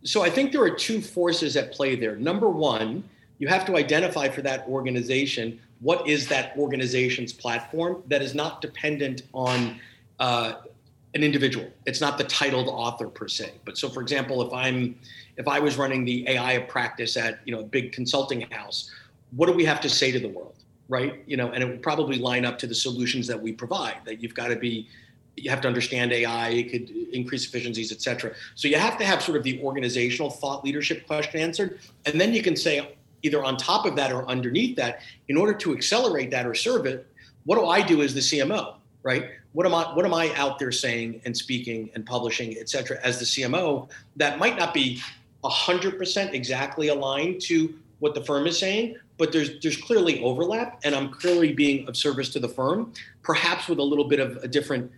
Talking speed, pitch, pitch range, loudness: 210 wpm, 135 Hz, 125-150 Hz, -25 LUFS